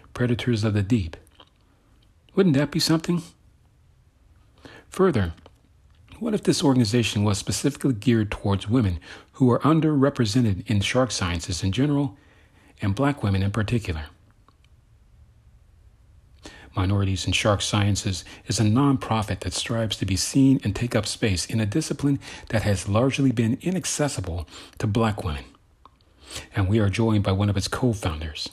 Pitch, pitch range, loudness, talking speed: 110 Hz, 95-130 Hz, -23 LUFS, 145 wpm